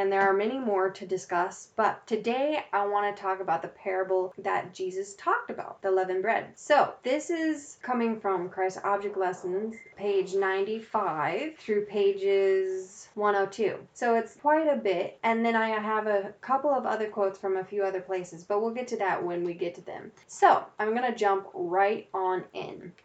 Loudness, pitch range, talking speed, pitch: -28 LUFS, 190-225 Hz, 195 wpm, 200 Hz